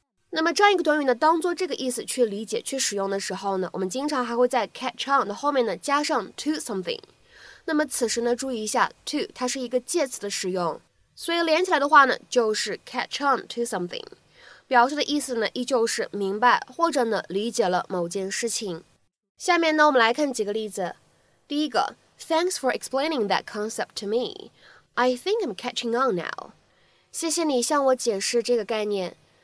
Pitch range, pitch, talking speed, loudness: 215-300 Hz, 250 Hz, 420 characters per minute, -24 LUFS